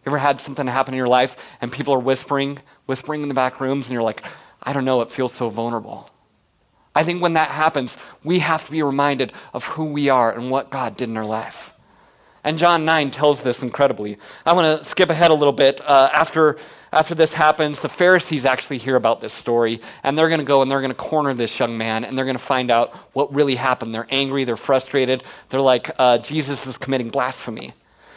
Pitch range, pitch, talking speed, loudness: 125-150 Hz, 135 Hz, 225 wpm, -19 LUFS